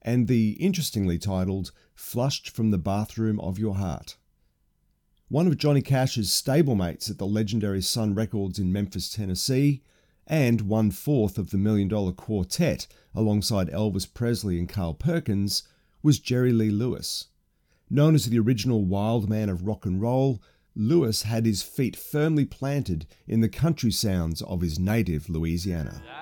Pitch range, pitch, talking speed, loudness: 95-120 Hz, 105 Hz, 150 wpm, -26 LUFS